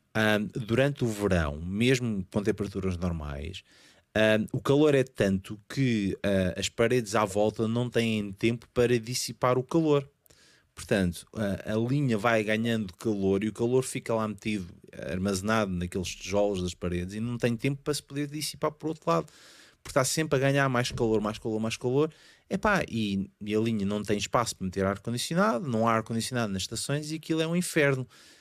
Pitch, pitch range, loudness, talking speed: 115 Hz, 100-130 Hz, -28 LUFS, 185 wpm